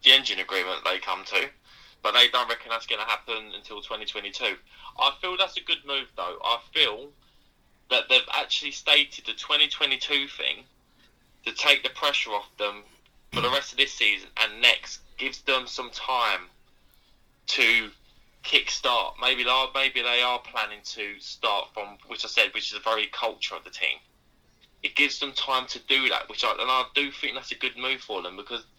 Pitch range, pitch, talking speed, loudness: 120-145 Hz, 130 Hz, 190 wpm, -24 LUFS